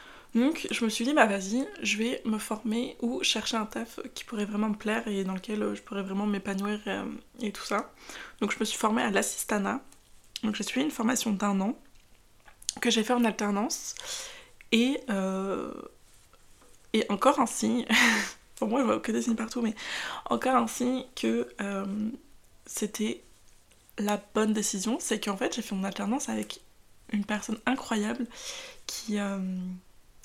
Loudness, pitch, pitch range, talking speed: -29 LUFS, 220 Hz, 200-245 Hz, 175 wpm